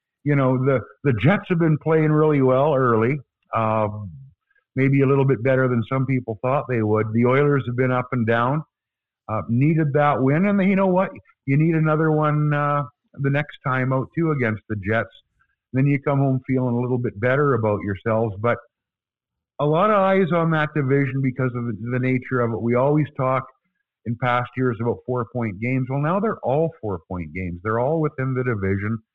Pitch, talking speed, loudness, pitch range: 130 Hz, 205 wpm, -21 LUFS, 120-150 Hz